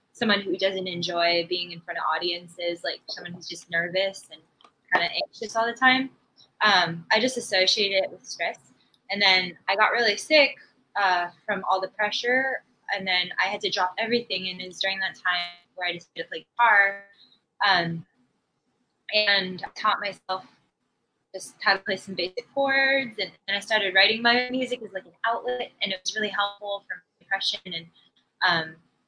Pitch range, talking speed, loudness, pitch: 180-220 Hz, 185 wpm, -24 LUFS, 195 Hz